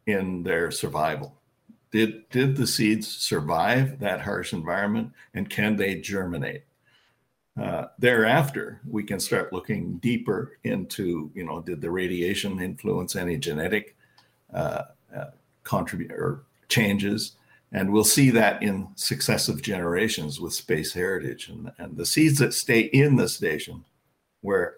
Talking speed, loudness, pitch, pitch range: 135 wpm, -25 LUFS, 110 Hz, 95-125 Hz